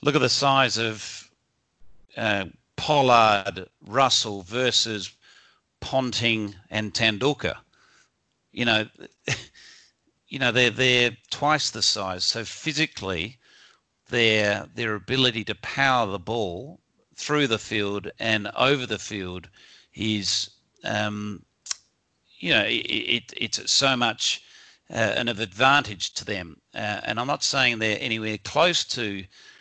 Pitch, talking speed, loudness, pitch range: 110 Hz, 120 wpm, -23 LUFS, 105-125 Hz